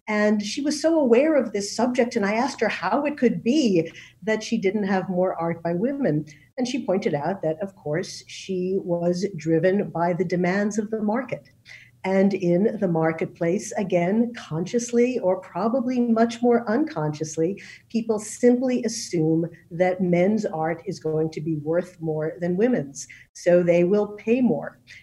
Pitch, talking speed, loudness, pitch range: 195 Hz, 170 wpm, -23 LUFS, 170-230 Hz